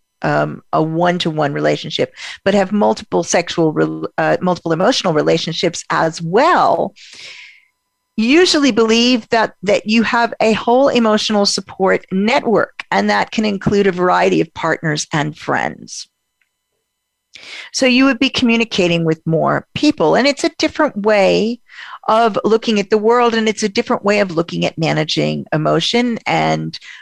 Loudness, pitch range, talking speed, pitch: -15 LUFS, 165-235 Hz, 145 wpm, 210 Hz